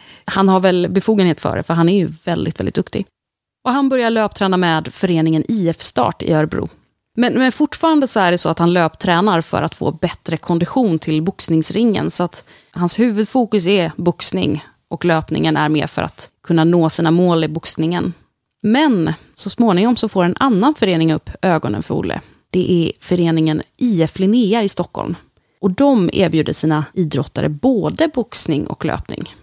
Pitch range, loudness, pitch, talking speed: 165-220 Hz, -16 LUFS, 180 Hz, 175 wpm